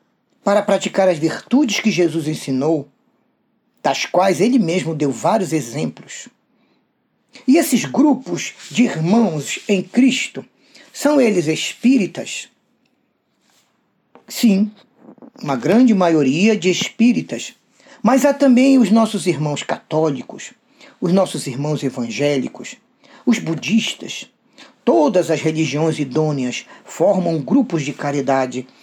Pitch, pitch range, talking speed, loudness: 200 Hz, 160-245 Hz, 105 wpm, -17 LUFS